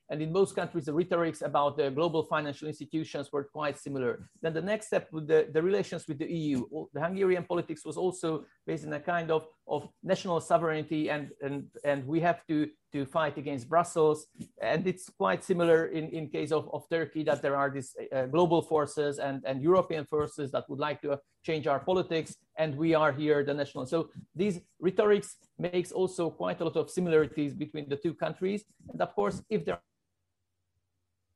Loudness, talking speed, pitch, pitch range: -31 LUFS, 195 wpm, 155 Hz, 145-170 Hz